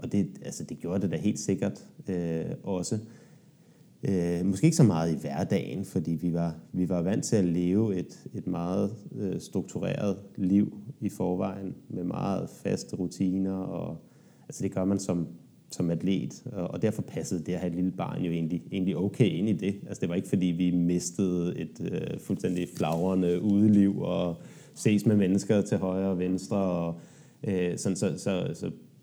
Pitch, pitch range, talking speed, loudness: 95 Hz, 85-100 Hz, 185 wpm, -29 LUFS